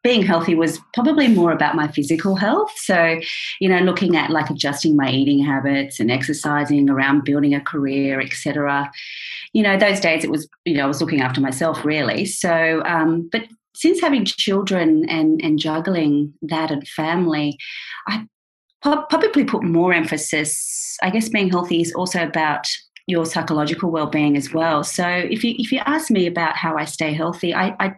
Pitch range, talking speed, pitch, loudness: 150-190 Hz, 180 wpm, 165 Hz, -19 LUFS